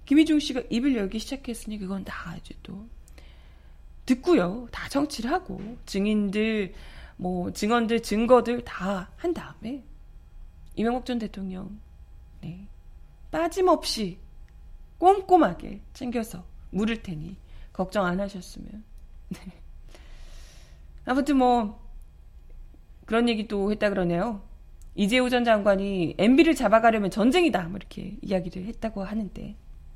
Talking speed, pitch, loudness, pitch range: 245 characters per minute, 210 Hz, -25 LUFS, 185-240 Hz